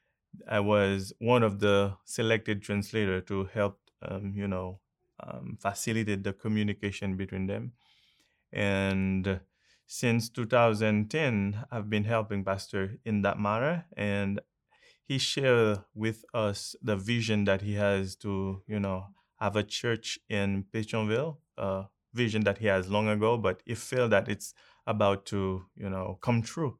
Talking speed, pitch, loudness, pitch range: 145 wpm, 105 Hz, -30 LUFS, 100-115 Hz